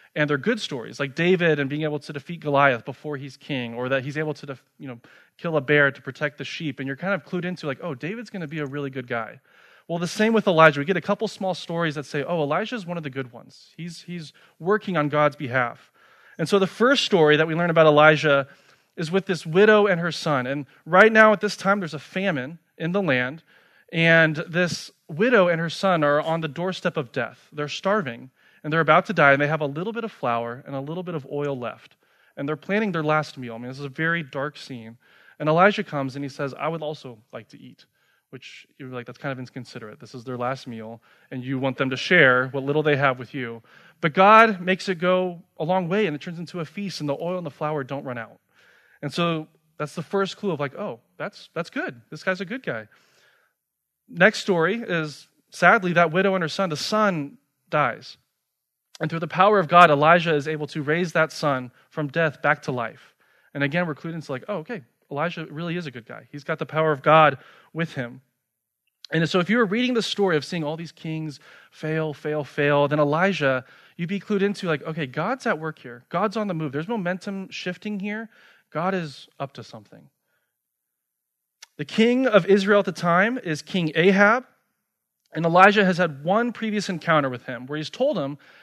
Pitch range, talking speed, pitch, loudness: 140-185 Hz, 230 wpm, 155 Hz, -22 LUFS